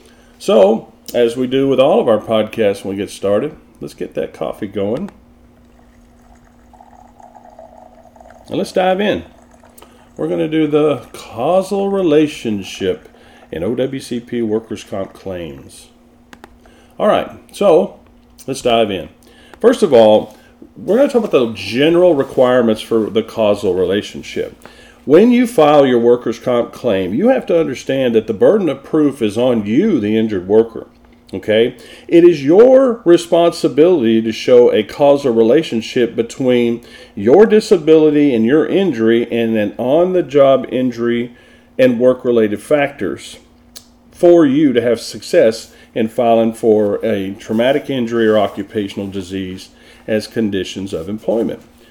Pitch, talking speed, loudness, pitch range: 120 Hz, 135 wpm, -14 LUFS, 110-160 Hz